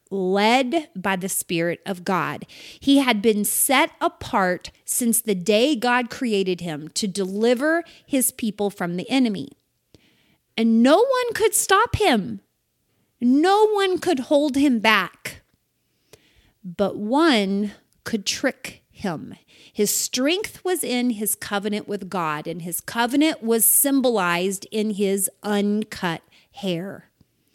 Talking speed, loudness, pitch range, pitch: 125 wpm, -21 LUFS, 195-275 Hz, 220 Hz